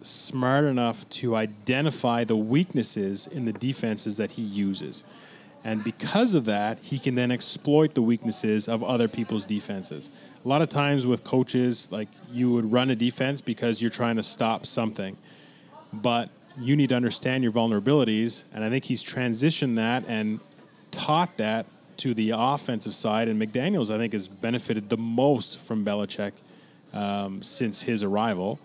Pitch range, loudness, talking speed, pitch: 110-130 Hz, -26 LUFS, 165 wpm, 115 Hz